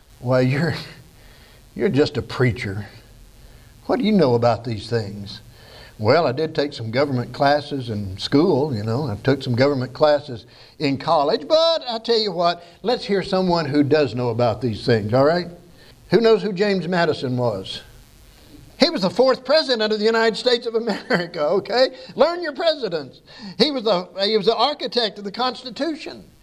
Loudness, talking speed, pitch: -20 LUFS, 175 wpm, 150 Hz